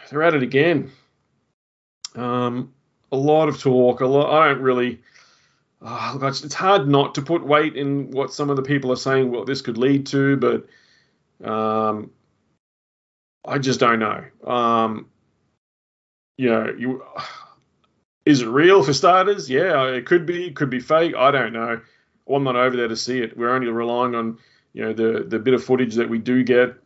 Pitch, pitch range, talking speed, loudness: 130 Hz, 120-140 Hz, 180 wpm, -20 LUFS